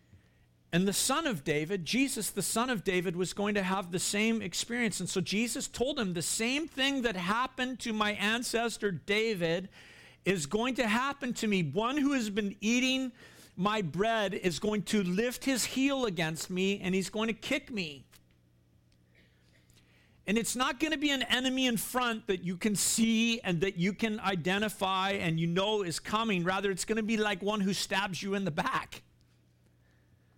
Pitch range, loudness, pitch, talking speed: 180-230 Hz, -31 LUFS, 205 Hz, 190 wpm